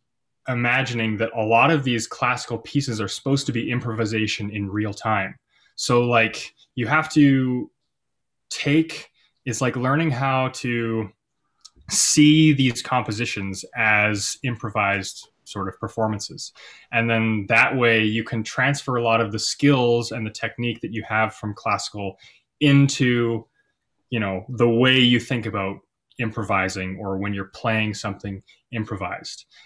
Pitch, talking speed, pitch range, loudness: 115 Hz, 140 wpm, 110-130 Hz, -21 LUFS